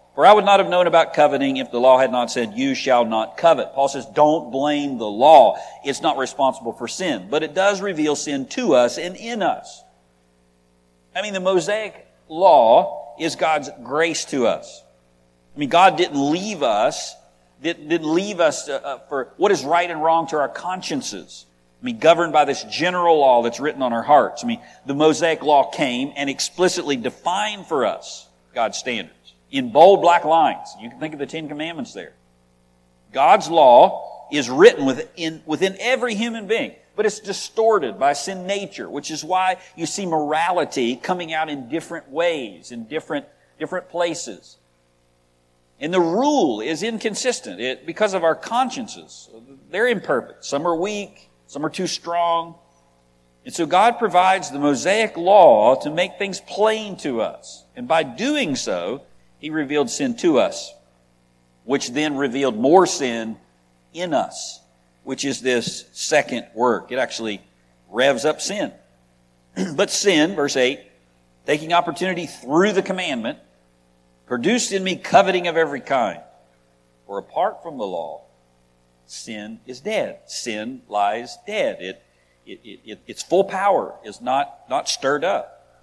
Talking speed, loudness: 160 wpm, -19 LUFS